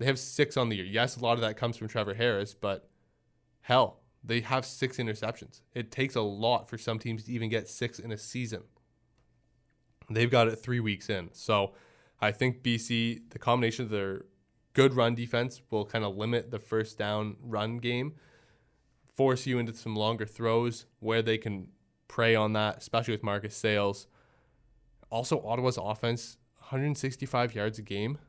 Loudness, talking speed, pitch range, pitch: -31 LUFS, 180 wpm, 110-125 Hz, 115 Hz